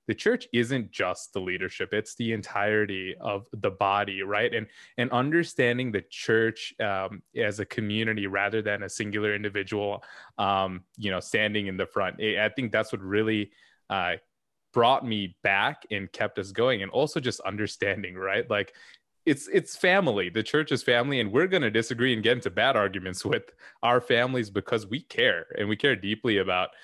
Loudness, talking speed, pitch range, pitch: -27 LUFS, 180 wpm, 100-120 Hz, 105 Hz